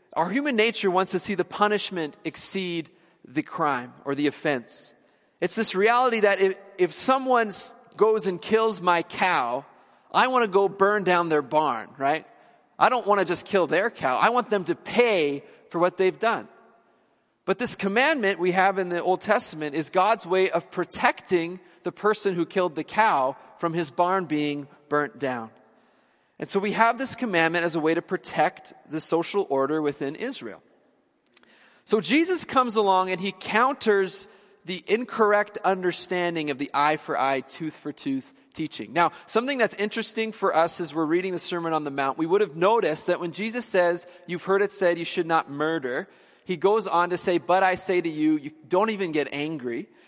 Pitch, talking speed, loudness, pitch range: 185 Hz, 190 wpm, -24 LUFS, 160-210 Hz